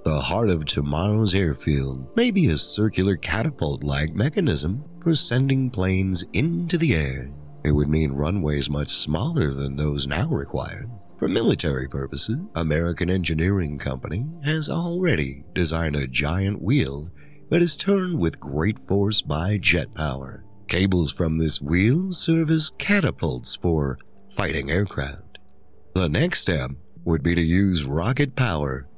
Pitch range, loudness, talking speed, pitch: 75-115 Hz, -23 LUFS, 140 wpm, 85 Hz